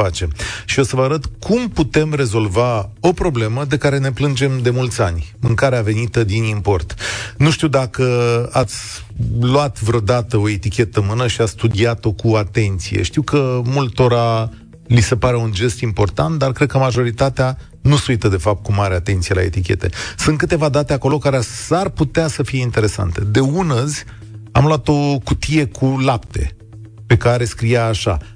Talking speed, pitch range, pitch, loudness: 175 wpm, 110-140 Hz, 120 Hz, -17 LUFS